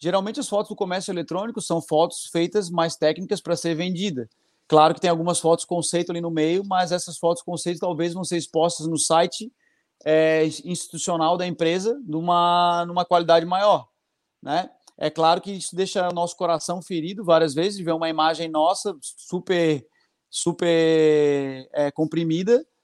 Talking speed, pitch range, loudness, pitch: 165 wpm, 160-180 Hz, -22 LUFS, 170 Hz